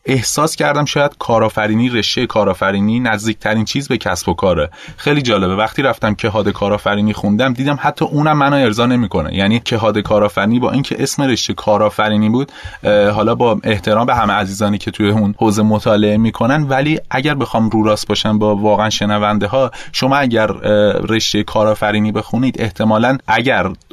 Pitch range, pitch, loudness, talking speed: 105-125 Hz, 110 Hz, -14 LUFS, 160 wpm